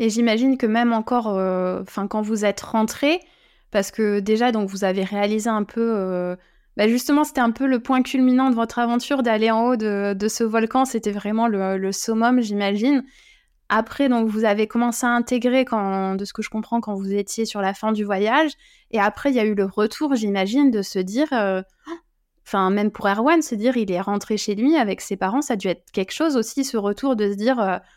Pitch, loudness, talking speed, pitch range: 220 Hz, -21 LUFS, 225 wpm, 205-250 Hz